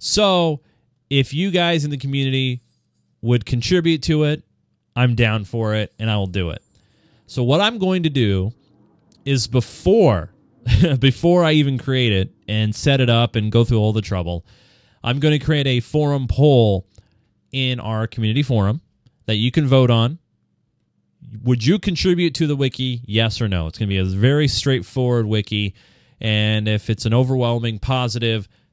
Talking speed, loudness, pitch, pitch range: 170 wpm, -19 LUFS, 120 Hz, 110-140 Hz